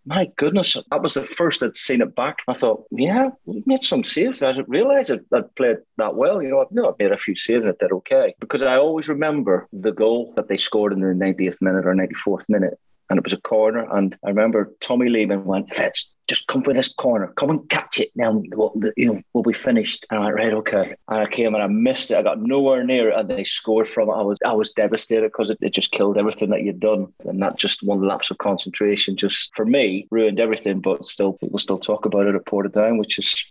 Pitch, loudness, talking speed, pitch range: 110 Hz, -20 LUFS, 255 wpm, 100-150 Hz